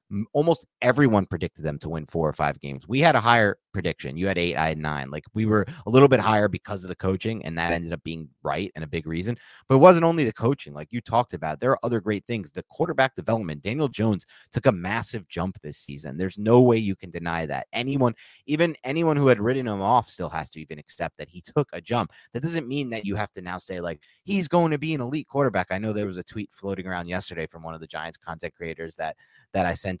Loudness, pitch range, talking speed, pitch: -24 LUFS, 85-125 Hz, 260 wpm, 100 Hz